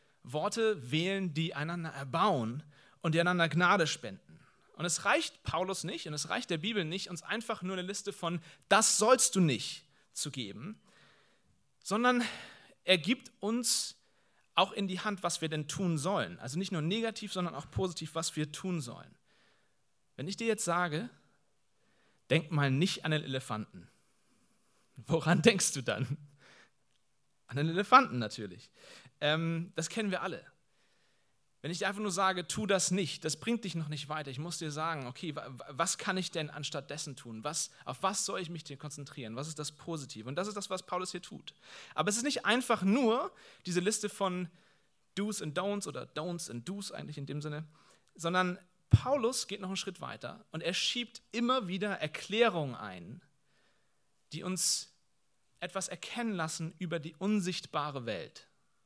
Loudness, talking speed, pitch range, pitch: -33 LUFS, 175 wpm, 150-200 Hz, 175 Hz